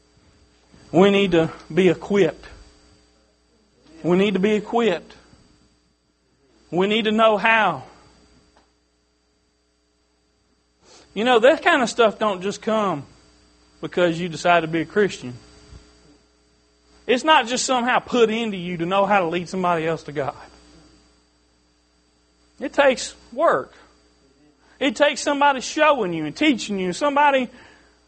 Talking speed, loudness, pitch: 125 wpm, -20 LUFS, 160 Hz